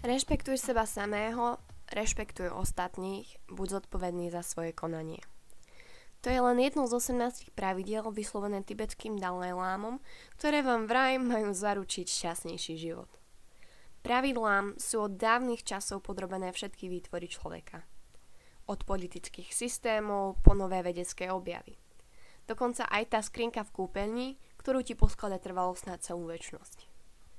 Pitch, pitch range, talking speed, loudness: 205 Hz, 180-235 Hz, 125 wpm, -33 LUFS